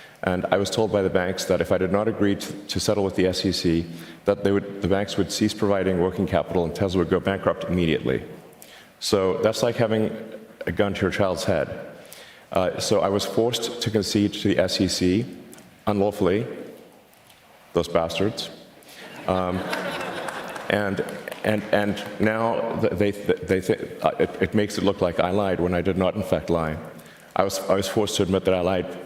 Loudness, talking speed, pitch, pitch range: -24 LUFS, 190 wpm, 95 Hz, 90-105 Hz